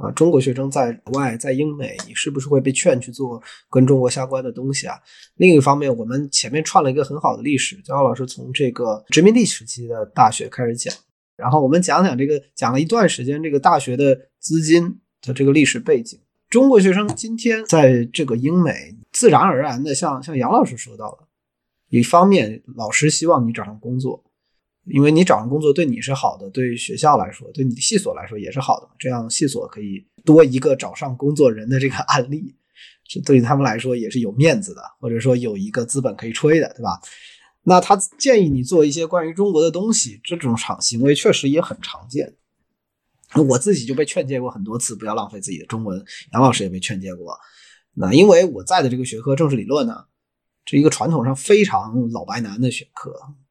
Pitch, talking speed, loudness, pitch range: 135 Hz, 320 characters per minute, -18 LUFS, 120-160 Hz